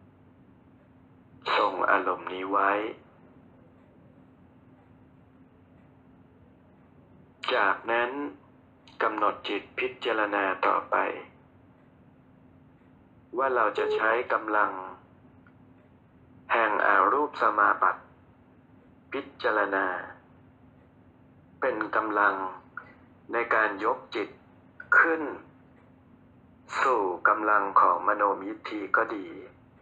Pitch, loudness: 330 Hz, -26 LUFS